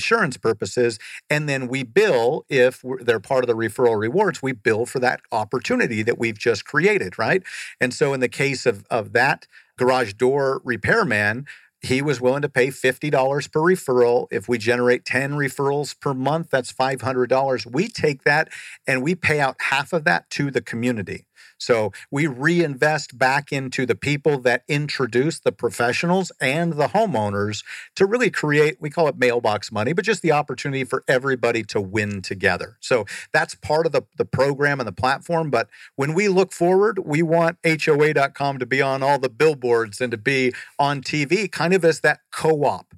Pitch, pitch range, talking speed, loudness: 135 Hz, 125-155 Hz, 180 wpm, -21 LUFS